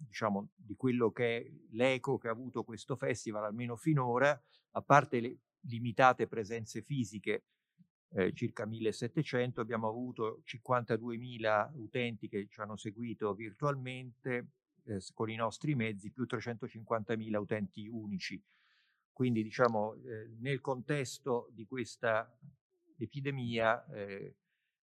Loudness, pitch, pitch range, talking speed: -36 LUFS, 120 Hz, 110-130 Hz, 120 wpm